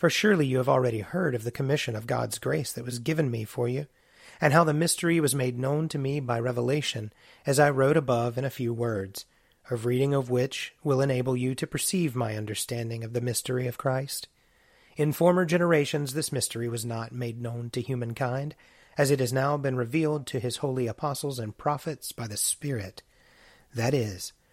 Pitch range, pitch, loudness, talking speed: 120-150 Hz, 130 Hz, -28 LUFS, 200 wpm